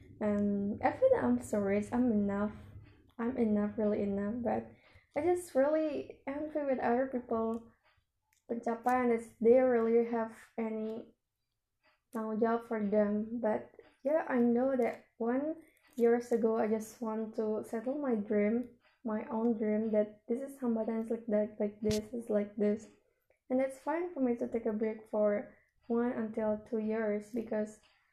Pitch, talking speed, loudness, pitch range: 230 Hz, 160 wpm, -33 LUFS, 215-245 Hz